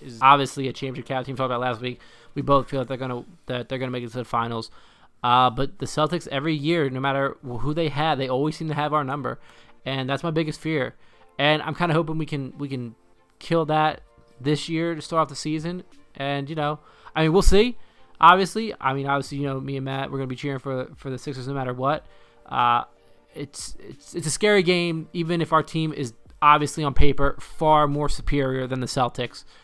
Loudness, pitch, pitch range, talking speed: -24 LUFS, 140 Hz, 130-155 Hz, 230 wpm